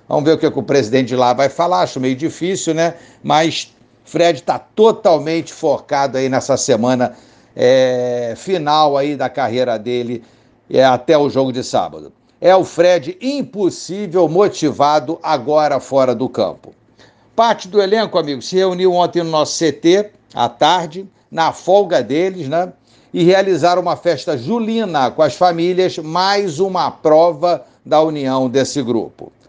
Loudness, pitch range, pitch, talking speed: -15 LUFS, 135-180 Hz, 160 Hz, 155 wpm